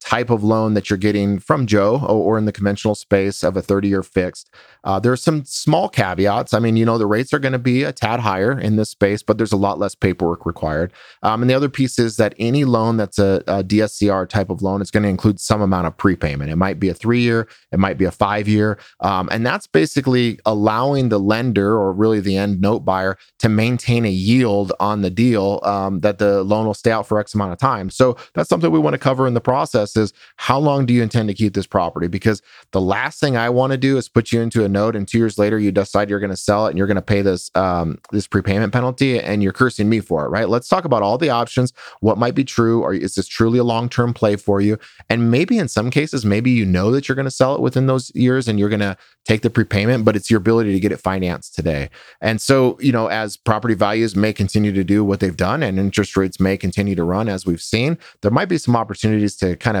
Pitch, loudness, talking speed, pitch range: 105 Hz, -18 LUFS, 260 wpm, 100-120 Hz